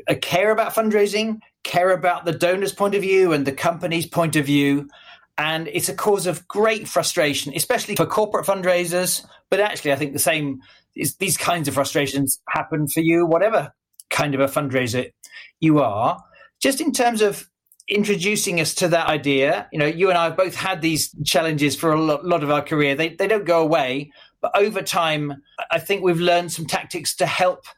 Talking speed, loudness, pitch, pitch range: 195 wpm, -20 LUFS, 170 Hz, 150-195 Hz